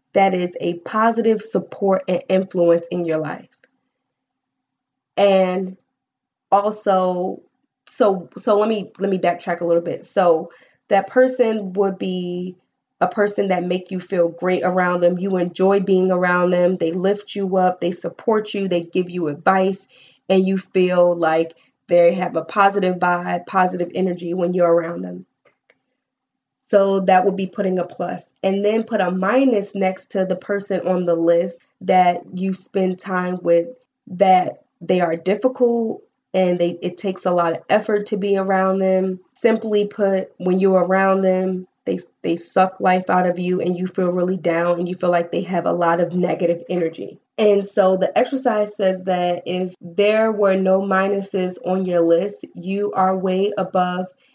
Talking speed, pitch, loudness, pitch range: 170 wpm, 185 Hz, -19 LUFS, 175-195 Hz